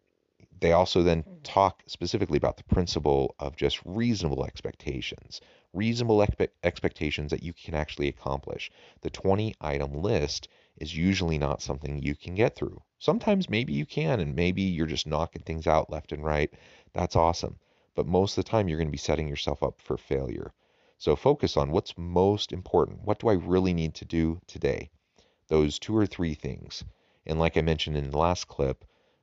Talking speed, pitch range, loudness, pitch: 185 wpm, 75-95 Hz, -28 LUFS, 80 Hz